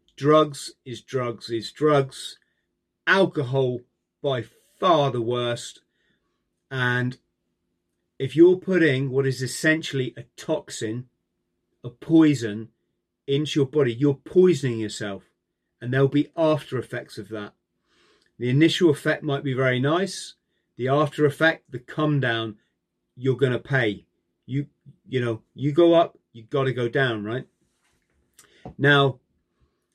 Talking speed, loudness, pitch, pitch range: 130 wpm, -23 LUFS, 130 Hz, 115-150 Hz